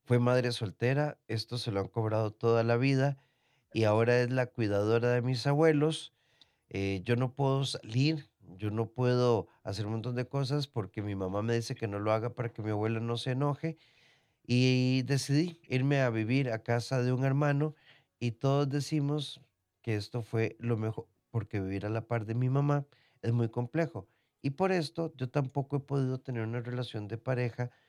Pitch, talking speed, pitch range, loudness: 125 Hz, 190 wpm, 115-140 Hz, -32 LUFS